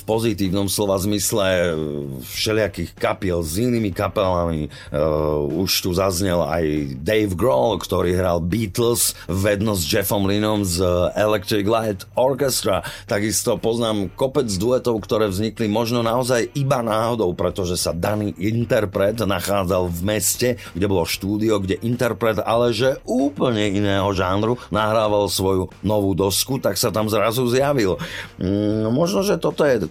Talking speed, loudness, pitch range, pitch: 135 wpm, -20 LUFS, 95-115 Hz, 105 Hz